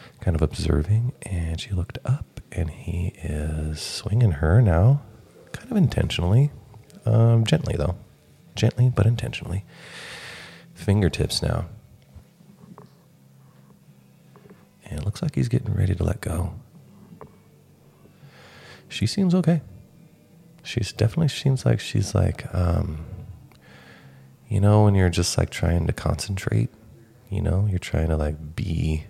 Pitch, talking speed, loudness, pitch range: 100 Hz, 125 wpm, -23 LUFS, 85-120 Hz